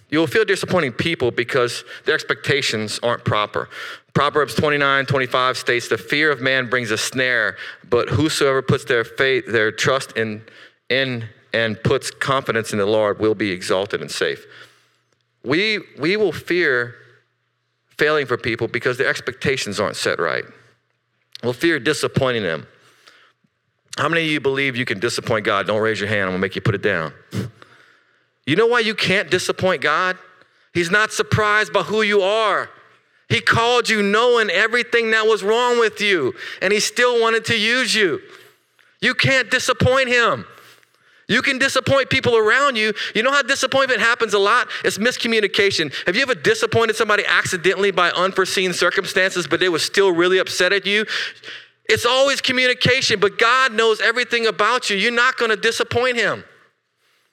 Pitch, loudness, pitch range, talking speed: 200 Hz, -18 LUFS, 140-235 Hz, 170 wpm